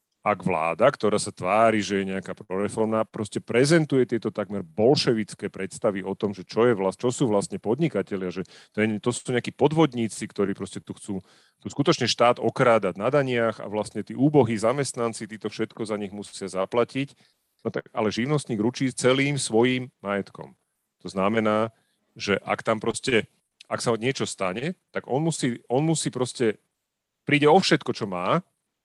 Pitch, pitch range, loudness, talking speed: 115 Hz, 100-125 Hz, -25 LUFS, 170 wpm